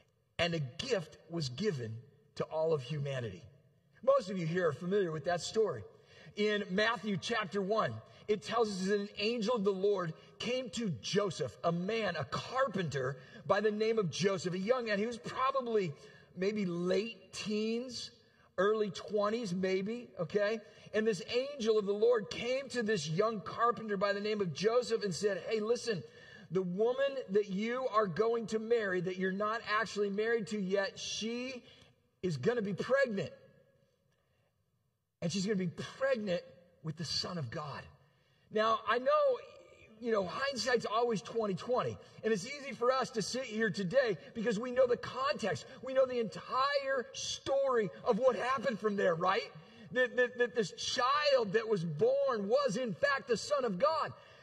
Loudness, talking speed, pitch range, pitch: -34 LUFS, 170 wpm, 180-235 Hz, 215 Hz